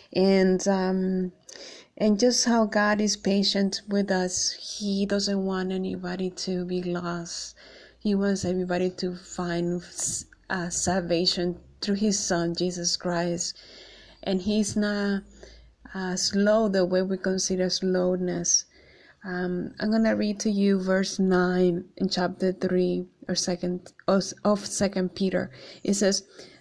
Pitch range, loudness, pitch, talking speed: 180-200 Hz, -26 LUFS, 185 Hz, 130 wpm